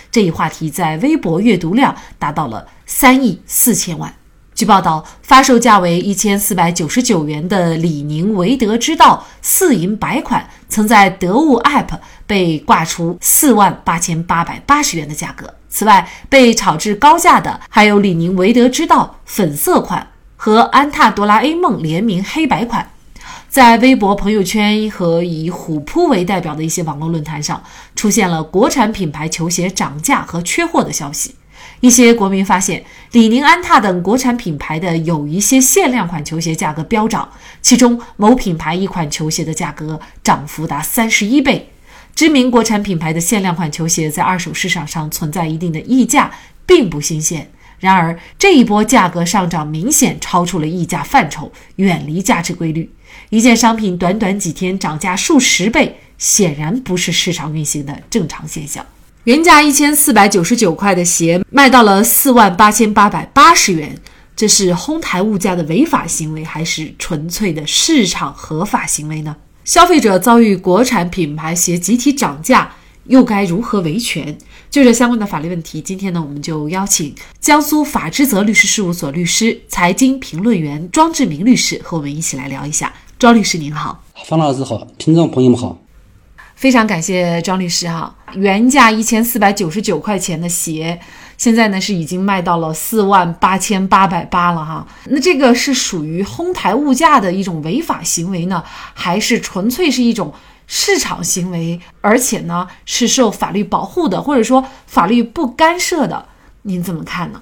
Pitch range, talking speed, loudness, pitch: 170-235 Hz, 270 characters per minute, -13 LUFS, 195 Hz